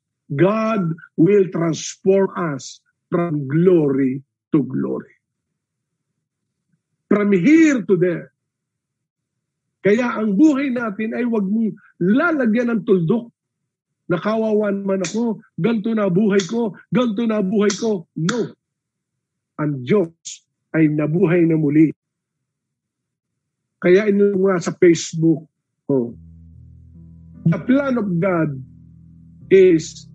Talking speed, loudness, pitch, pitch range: 100 wpm, -18 LUFS, 175 Hz, 145-205 Hz